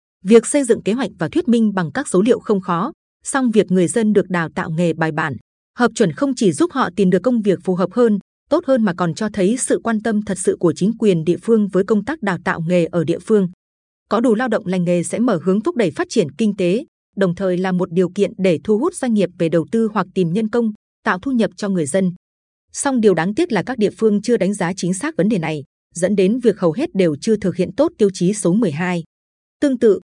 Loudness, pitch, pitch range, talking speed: -18 LUFS, 200 Hz, 180-230 Hz, 265 wpm